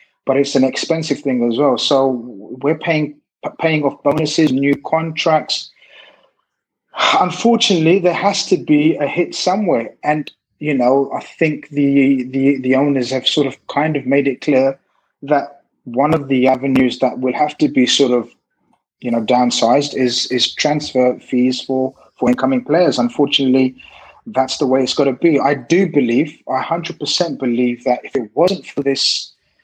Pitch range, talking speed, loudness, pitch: 130-150 Hz, 170 wpm, -16 LUFS, 140 Hz